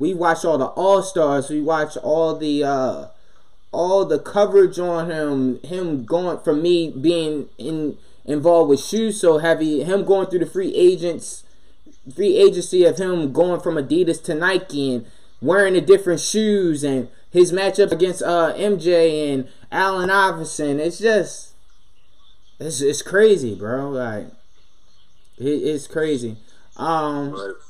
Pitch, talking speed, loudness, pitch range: 165 Hz, 145 wpm, -19 LUFS, 145-185 Hz